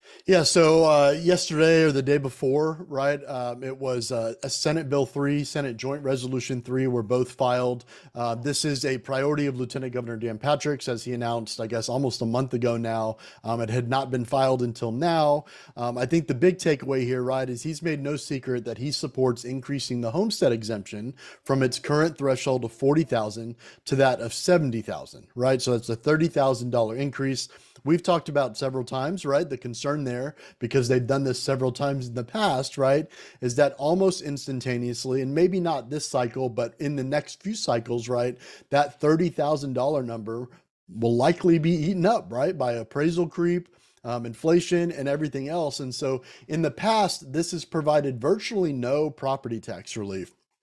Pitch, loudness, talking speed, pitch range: 135 Hz, -25 LUFS, 180 wpm, 125-150 Hz